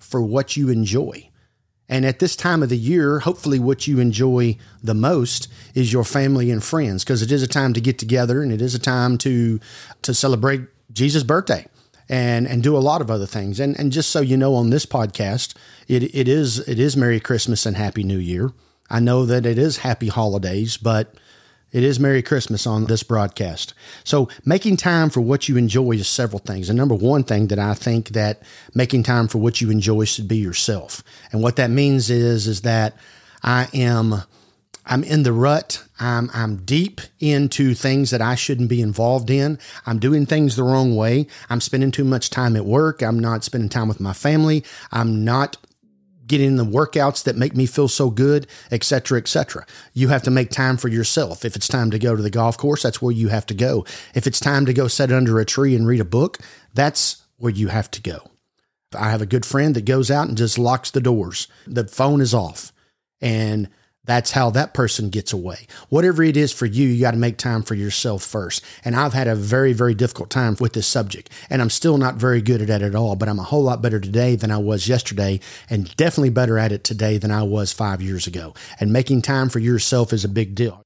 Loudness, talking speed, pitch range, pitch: -19 LUFS, 225 wpm, 110-135 Hz, 120 Hz